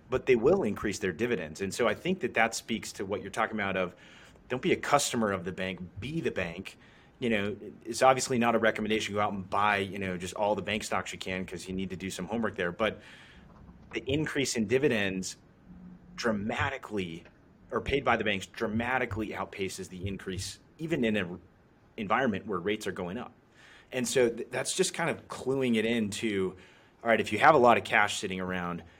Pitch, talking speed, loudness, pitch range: 105 Hz, 215 wpm, -30 LUFS, 95-115 Hz